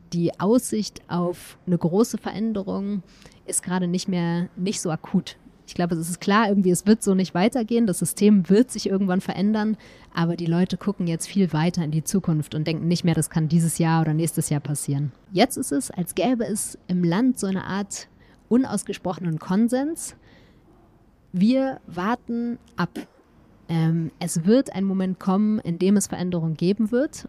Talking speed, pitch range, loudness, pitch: 175 wpm, 170-210 Hz, -23 LUFS, 185 Hz